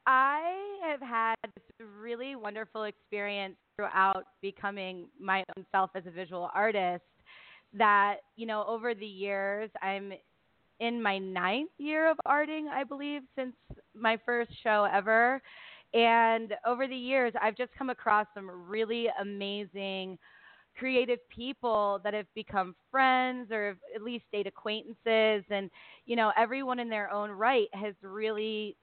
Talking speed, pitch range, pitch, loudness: 145 wpm, 200-240 Hz, 215 Hz, -31 LUFS